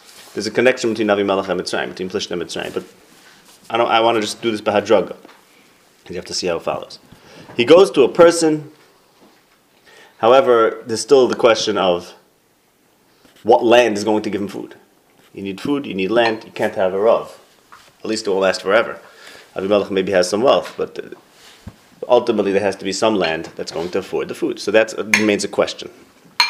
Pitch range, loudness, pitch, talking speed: 100-115 Hz, -17 LUFS, 110 Hz, 200 wpm